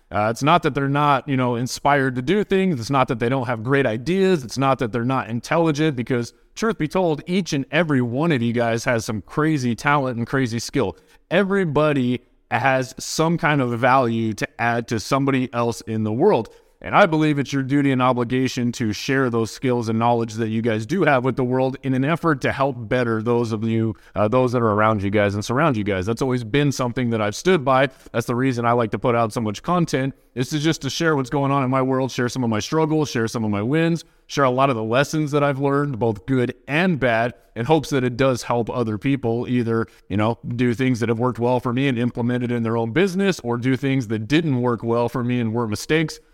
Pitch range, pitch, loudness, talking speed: 120-145 Hz, 130 Hz, -21 LUFS, 245 wpm